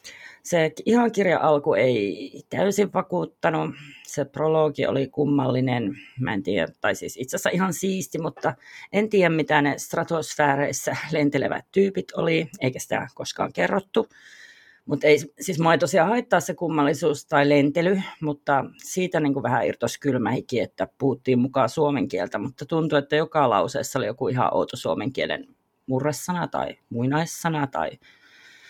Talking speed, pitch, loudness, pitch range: 150 wpm, 155 Hz, -24 LUFS, 145-185 Hz